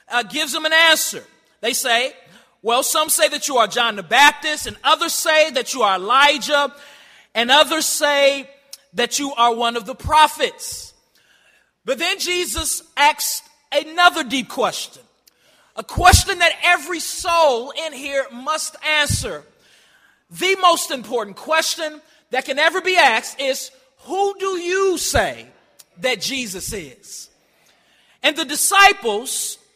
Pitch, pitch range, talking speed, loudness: 300 Hz, 260-330 Hz, 140 wpm, -17 LUFS